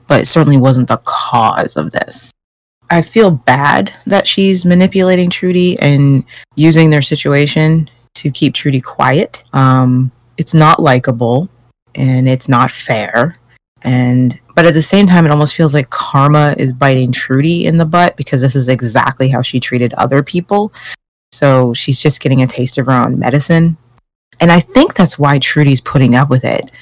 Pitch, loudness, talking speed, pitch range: 140 Hz, -10 LUFS, 170 wpm, 130-165 Hz